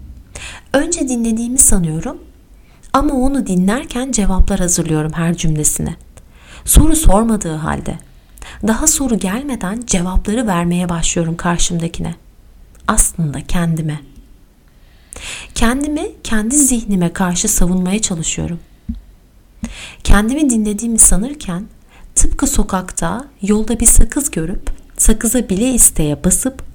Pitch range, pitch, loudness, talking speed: 170-245 Hz, 200 Hz, -15 LUFS, 90 wpm